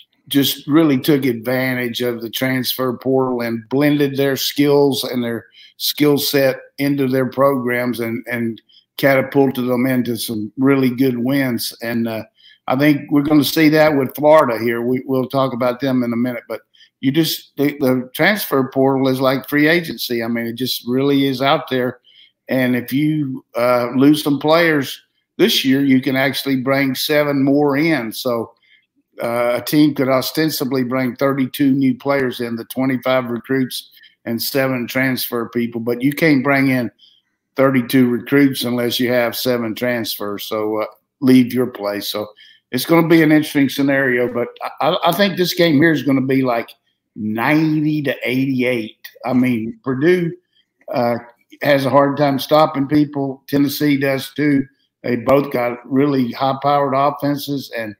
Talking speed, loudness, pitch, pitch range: 170 wpm, -17 LUFS, 130 Hz, 125-140 Hz